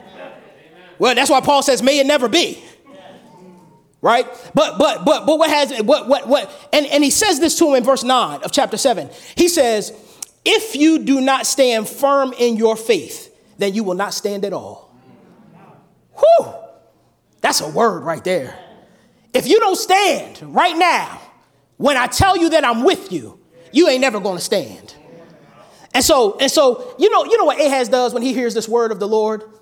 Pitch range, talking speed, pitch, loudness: 225-320 Hz, 190 wpm, 275 Hz, -16 LUFS